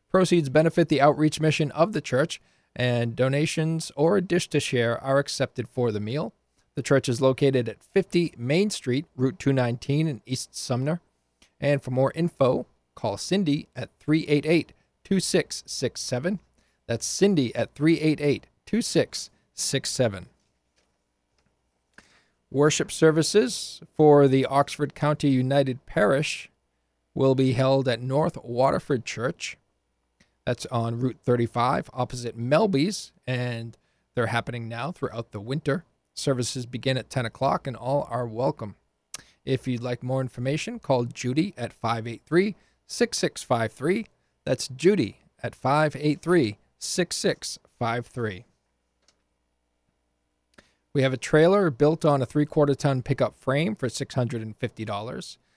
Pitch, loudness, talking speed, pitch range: 135 Hz, -25 LUFS, 120 wpm, 120-155 Hz